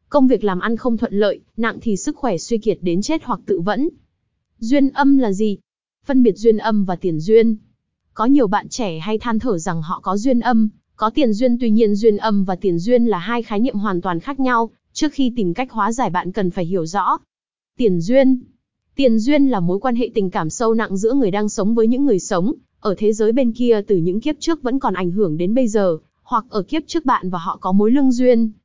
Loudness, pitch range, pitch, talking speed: -18 LUFS, 195-250 Hz, 220 Hz, 245 wpm